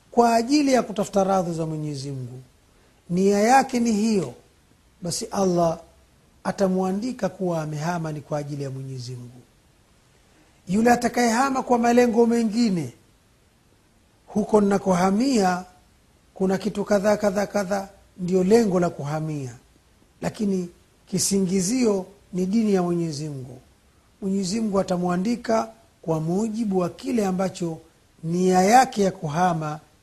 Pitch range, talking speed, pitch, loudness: 160-215 Hz, 110 wpm, 190 Hz, -23 LUFS